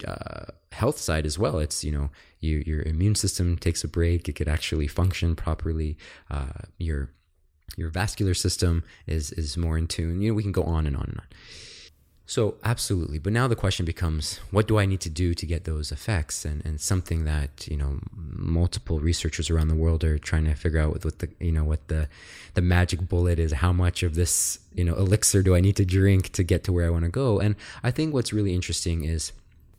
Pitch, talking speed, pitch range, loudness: 85 Hz, 225 wpm, 80-95 Hz, -26 LUFS